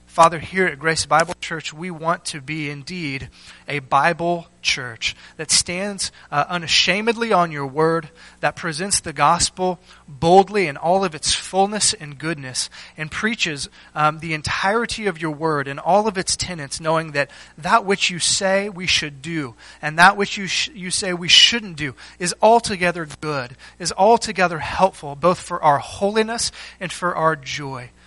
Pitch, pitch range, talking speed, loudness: 170 Hz, 150-190 Hz, 170 wpm, -19 LUFS